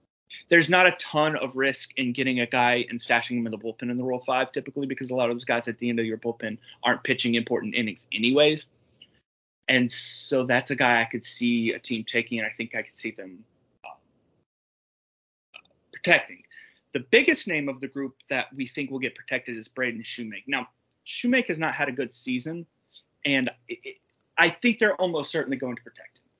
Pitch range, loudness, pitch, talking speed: 120-150 Hz, -25 LUFS, 130 Hz, 210 wpm